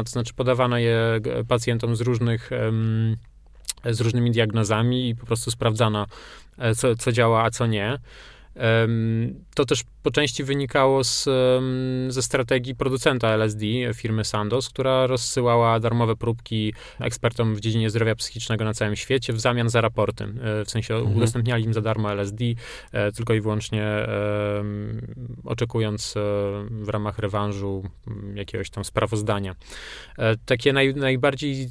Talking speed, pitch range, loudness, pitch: 130 wpm, 110-125 Hz, -23 LUFS, 115 Hz